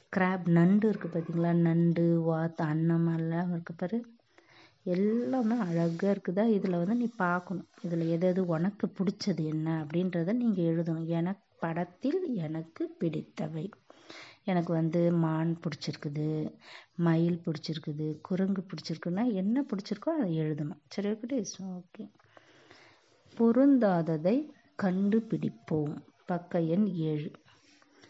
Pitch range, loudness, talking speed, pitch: 165-200 Hz, -30 LUFS, 100 wpm, 175 Hz